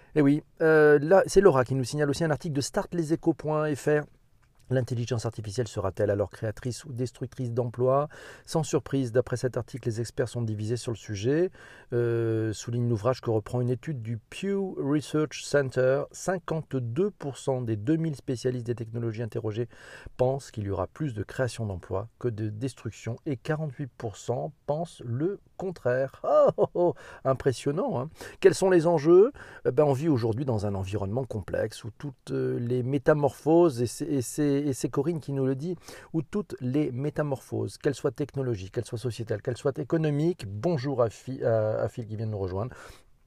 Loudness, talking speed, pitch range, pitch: -28 LUFS, 170 wpm, 120-150 Hz, 130 Hz